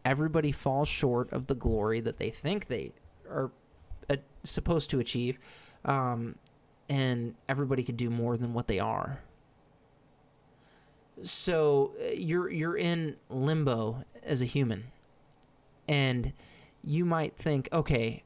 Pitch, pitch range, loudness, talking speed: 135 Hz, 120-150 Hz, -31 LUFS, 120 wpm